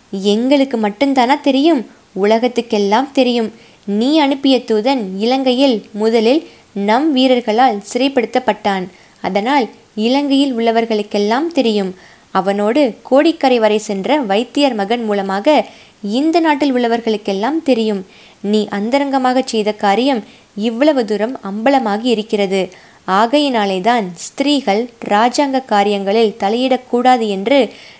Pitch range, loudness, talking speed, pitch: 210-265 Hz, -15 LUFS, 90 wpm, 235 Hz